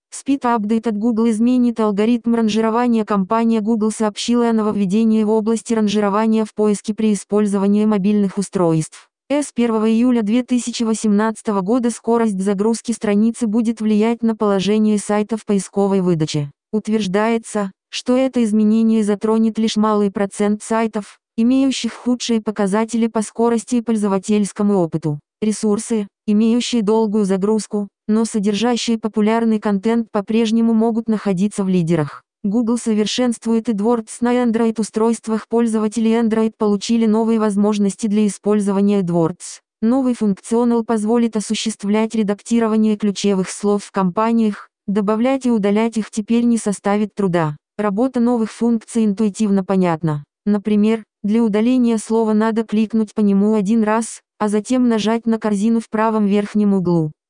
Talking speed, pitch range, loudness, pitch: 125 wpm, 205-230 Hz, -18 LUFS, 220 Hz